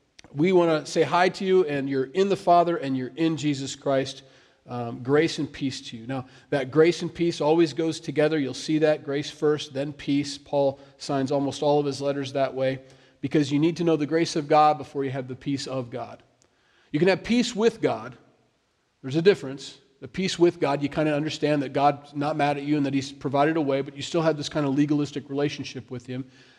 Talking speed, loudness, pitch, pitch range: 230 wpm, -25 LUFS, 145 Hz, 135-160 Hz